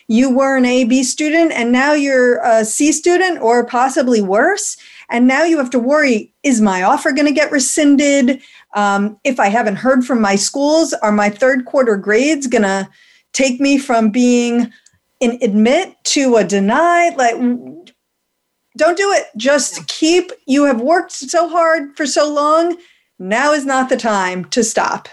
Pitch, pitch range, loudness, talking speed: 265 Hz, 230-300 Hz, -14 LUFS, 175 wpm